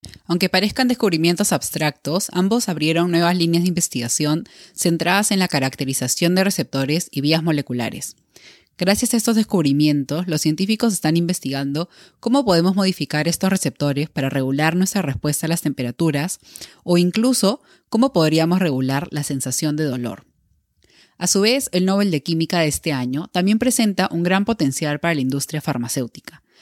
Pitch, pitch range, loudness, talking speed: 170 Hz, 145-190 Hz, -19 LUFS, 150 wpm